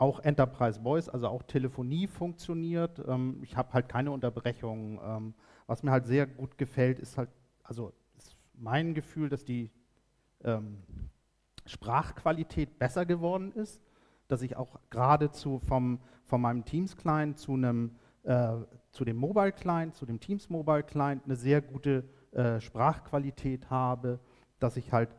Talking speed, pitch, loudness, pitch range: 140 wpm, 130 Hz, -32 LUFS, 120-150 Hz